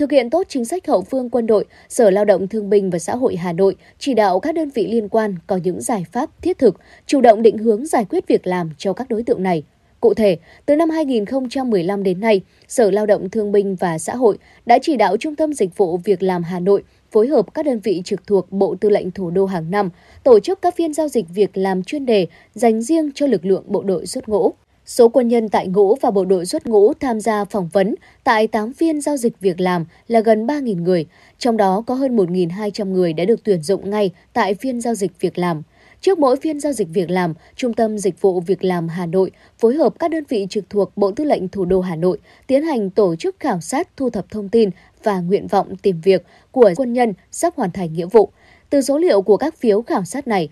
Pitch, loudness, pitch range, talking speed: 210 Hz, -18 LUFS, 190-250 Hz, 245 wpm